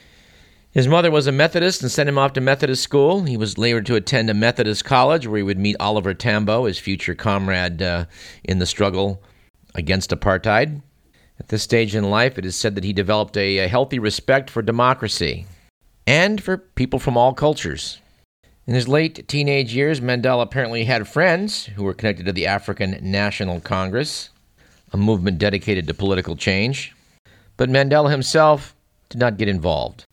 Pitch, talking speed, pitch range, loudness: 105 Hz, 175 wpm, 95-130 Hz, -19 LUFS